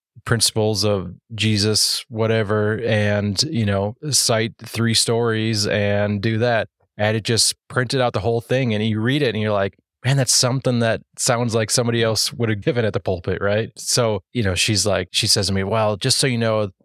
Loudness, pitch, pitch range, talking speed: -19 LUFS, 110 Hz, 105-120 Hz, 205 wpm